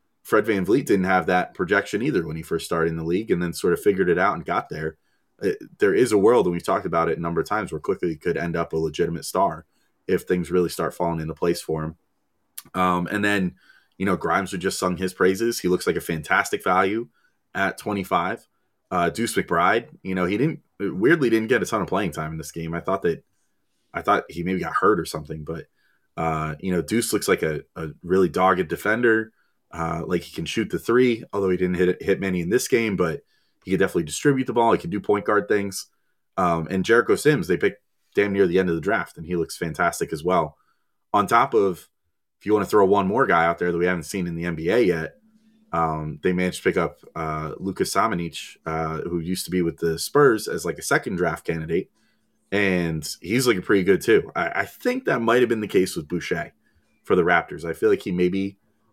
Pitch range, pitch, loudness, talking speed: 80-100 Hz, 90 Hz, -23 LUFS, 240 wpm